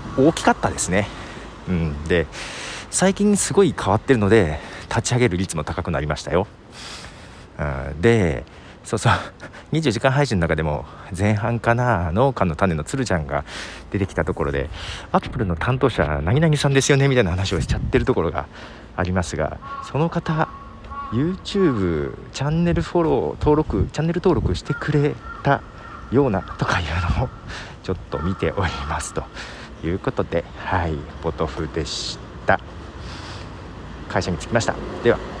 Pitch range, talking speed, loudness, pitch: 80-135 Hz, 325 characters per minute, -21 LUFS, 95 Hz